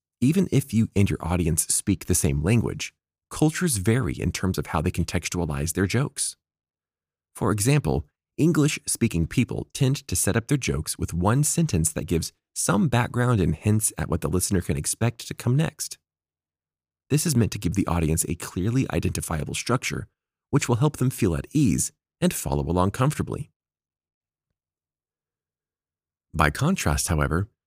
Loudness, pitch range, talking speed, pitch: -24 LUFS, 80-125 Hz, 160 wpm, 90 Hz